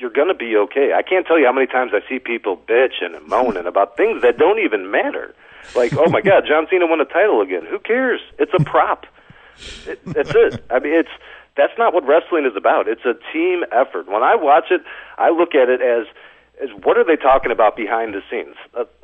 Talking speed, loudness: 230 wpm, -17 LUFS